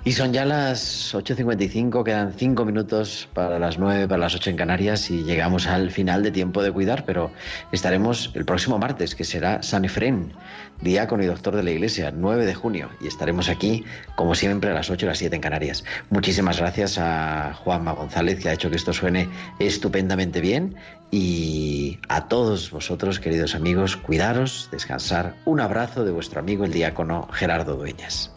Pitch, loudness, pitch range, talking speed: 95 Hz, -23 LUFS, 85-105 Hz, 180 wpm